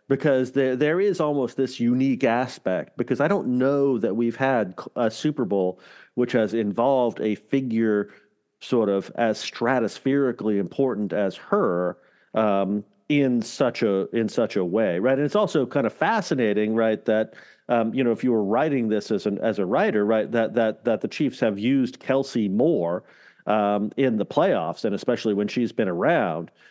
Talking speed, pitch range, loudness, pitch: 180 wpm, 105-135 Hz, -23 LUFS, 115 Hz